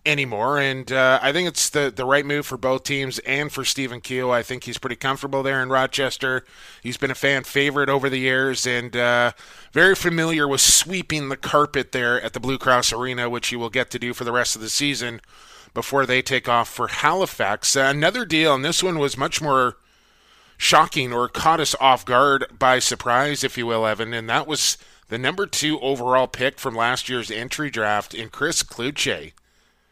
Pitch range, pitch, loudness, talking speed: 125-140 Hz, 130 Hz, -20 LUFS, 205 wpm